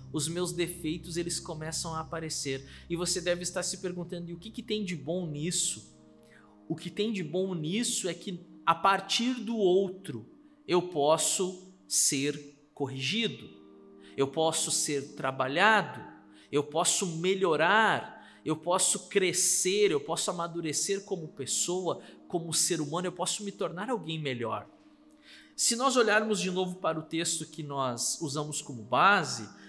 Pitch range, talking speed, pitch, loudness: 150-190 Hz, 150 wpm, 170 Hz, -29 LUFS